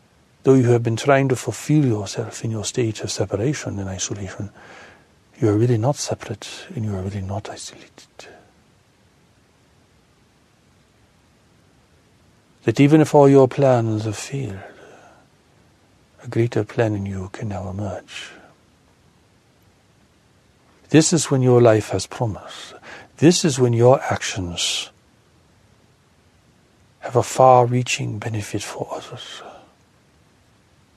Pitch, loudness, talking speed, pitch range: 115 Hz, -19 LUFS, 120 wpm, 100-130 Hz